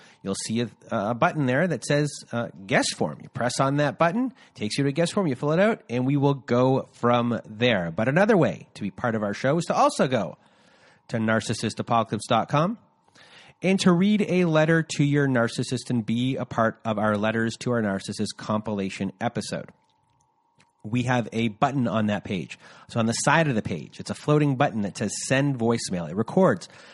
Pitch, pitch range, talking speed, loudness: 125 Hz, 115-150 Hz, 205 wpm, -24 LUFS